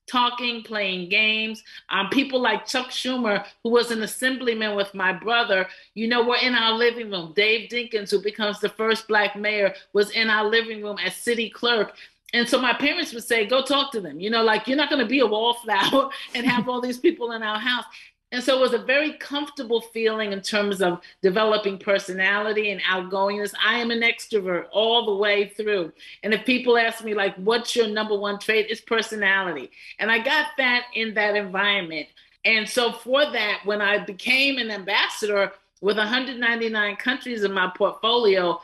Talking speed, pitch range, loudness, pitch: 195 wpm, 205-240 Hz, -22 LUFS, 220 Hz